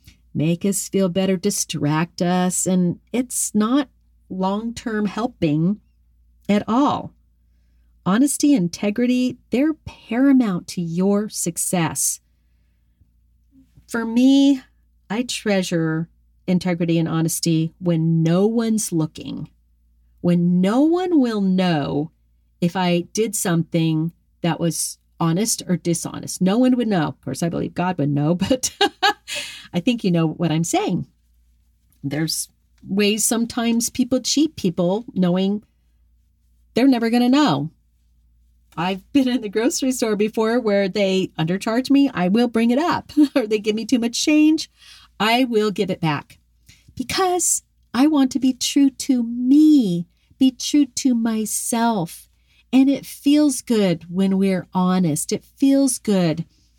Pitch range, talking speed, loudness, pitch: 160-245 Hz, 135 wpm, -20 LUFS, 190 Hz